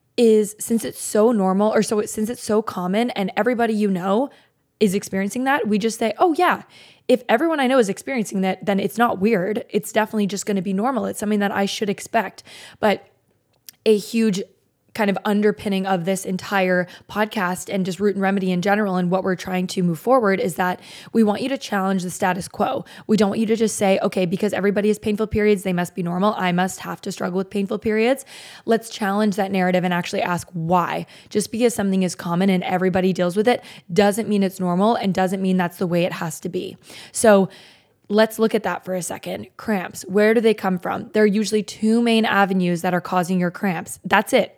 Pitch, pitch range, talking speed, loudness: 200 Hz, 185-220 Hz, 225 wpm, -21 LUFS